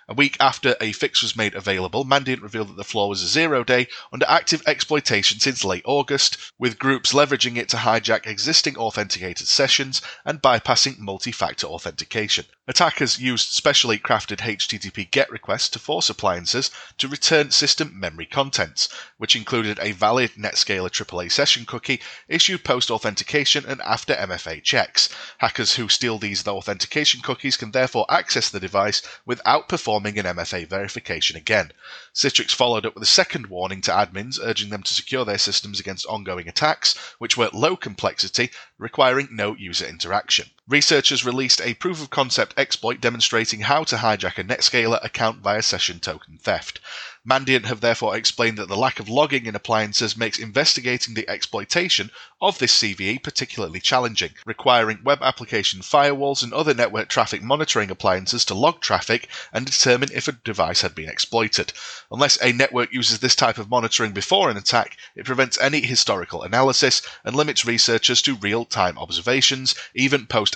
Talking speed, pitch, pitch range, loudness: 165 wpm, 120 Hz, 105-135 Hz, -20 LUFS